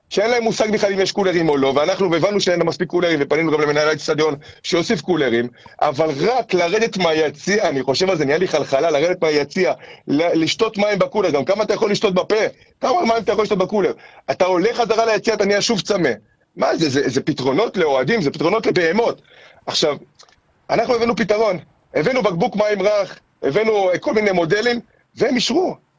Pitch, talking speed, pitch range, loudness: 190 Hz, 185 wpm, 155-220 Hz, -18 LUFS